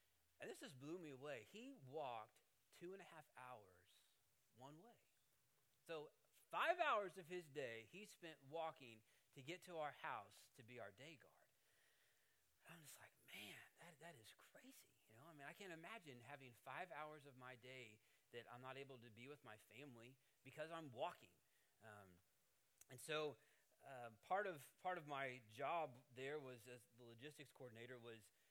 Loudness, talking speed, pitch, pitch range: -54 LUFS, 180 wpm, 135 Hz, 120-160 Hz